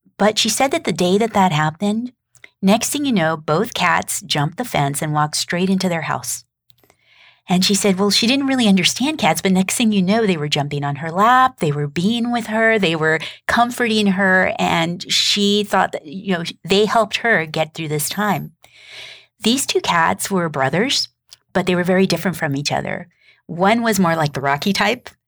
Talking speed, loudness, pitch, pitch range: 205 wpm, -17 LUFS, 190 Hz, 160-220 Hz